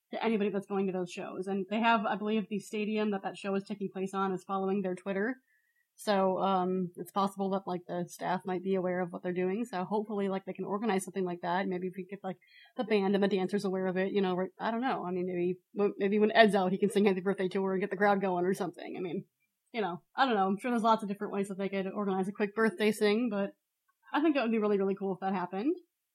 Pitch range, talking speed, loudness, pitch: 185-210 Hz, 275 wpm, -32 LUFS, 195 Hz